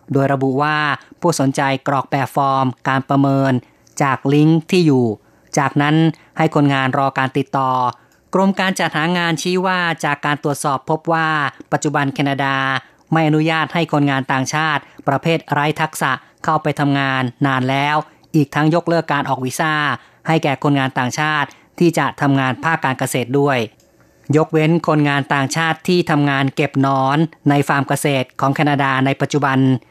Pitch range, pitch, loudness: 135-155 Hz, 145 Hz, -17 LUFS